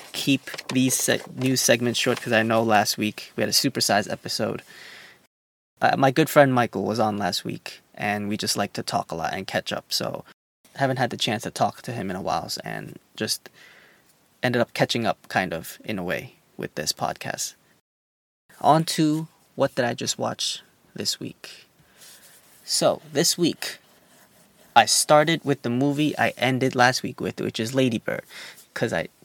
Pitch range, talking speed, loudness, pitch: 105-140 Hz, 185 wpm, -23 LUFS, 125 Hz